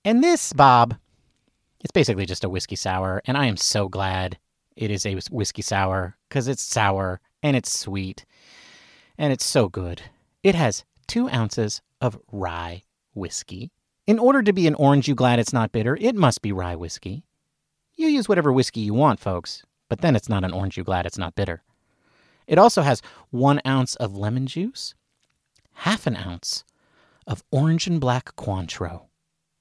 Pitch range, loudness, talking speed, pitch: 95-140 Hz, -22 LUFS, 175 wpm, 115 Hz